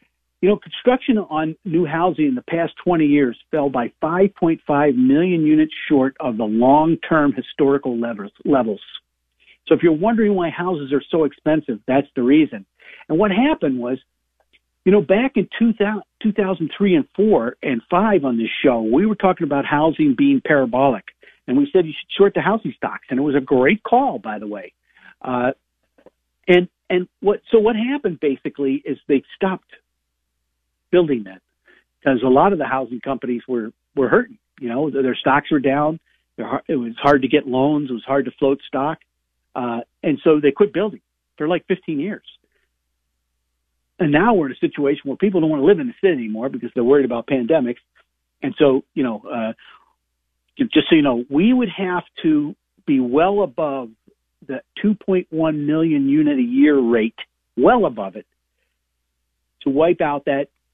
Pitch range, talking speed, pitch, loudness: 125-200 Hz, 185 wpm, 155 Hz, -18 LUFS